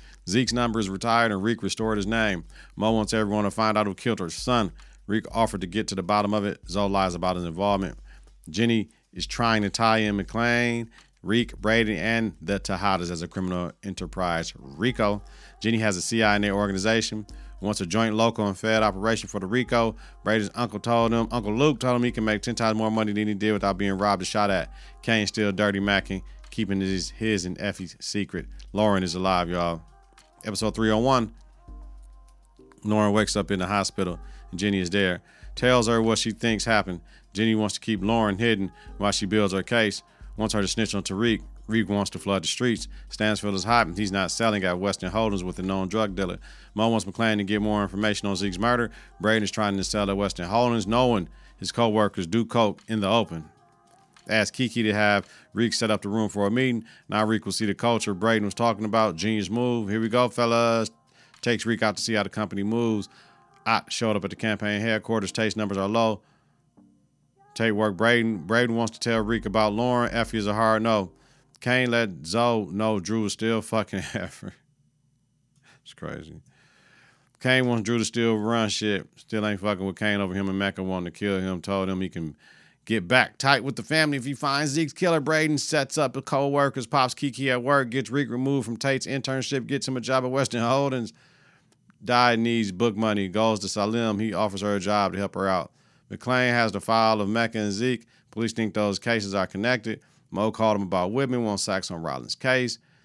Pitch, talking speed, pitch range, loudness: 110 Hz, 210 wpm, 100-115 Hz, -25 LUFS